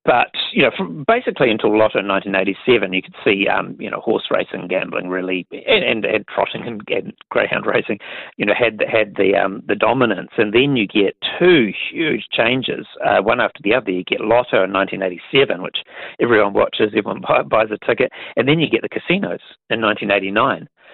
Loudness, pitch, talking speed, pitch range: -17 LUFS, 95 Hz, 210 wpm, 95-110 Hz